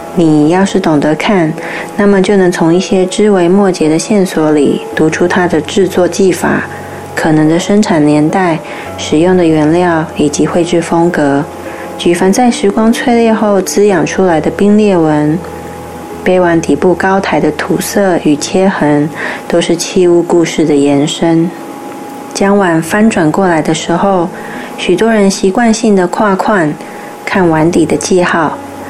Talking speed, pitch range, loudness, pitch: 225 characters per minute, 160-195 Hz, -10 LUFS, 175 Hz